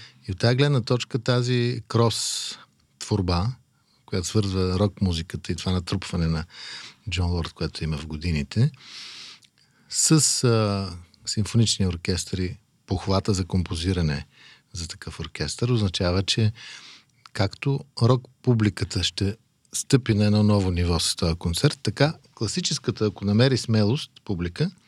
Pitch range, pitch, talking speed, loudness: 90-125 Hz, 105 Hz, 125 wpm, -24 LUFS